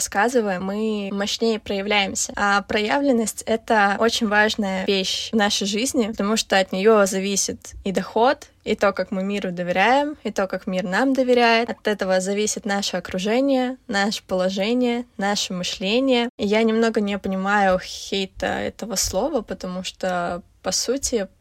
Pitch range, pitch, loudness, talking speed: 195-230 Hz, 205 Hz, -21 LUFS, 150 wpm